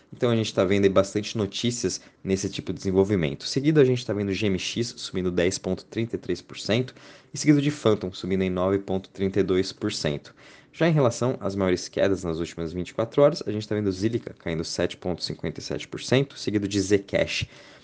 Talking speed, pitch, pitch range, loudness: 160 wpm, 100 Hz, 95-120 Hz, -25 LUFS